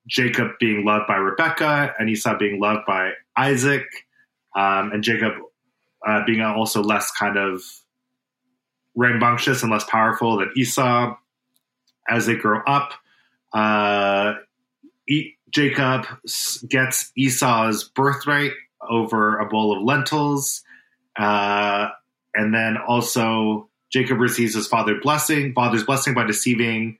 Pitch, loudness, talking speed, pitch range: 120 Hz, -20 LUFS, 120 wpm, 110-130 Hz